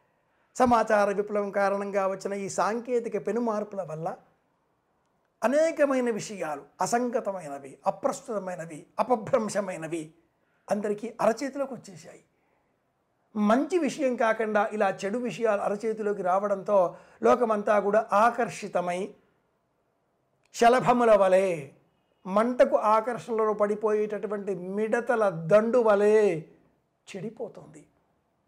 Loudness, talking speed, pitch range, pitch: -26 LUFS, 75 wpm, 195-230 Hz, 210 Hz